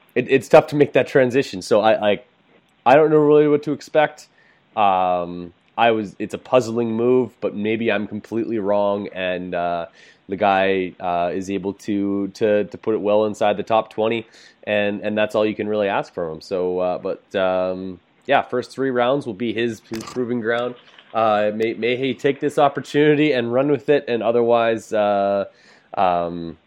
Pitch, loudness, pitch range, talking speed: 110 Hz, -20 LUFS, 100-125 Hz, 190 wpm